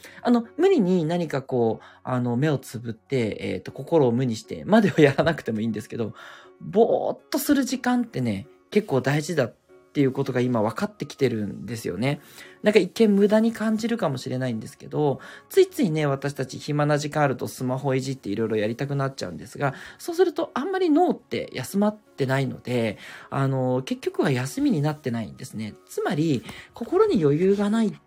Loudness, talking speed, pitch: -24 LUFS, 400 characters per minute, 140 Hz